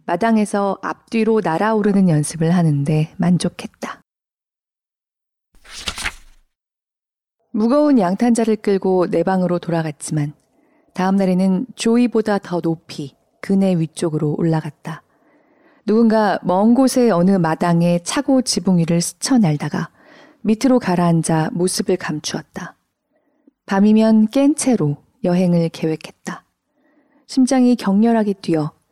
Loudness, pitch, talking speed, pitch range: -17 LUFS, 195 Hz, 250 characters per minute, 170-230 Hz